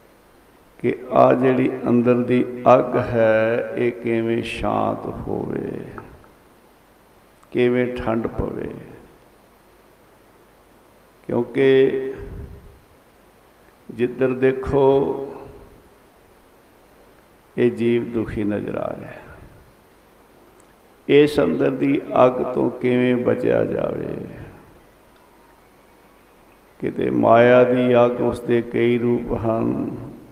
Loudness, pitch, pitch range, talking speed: -19 LUFS, 120 Hz, 115-125 Hz, 75 wpm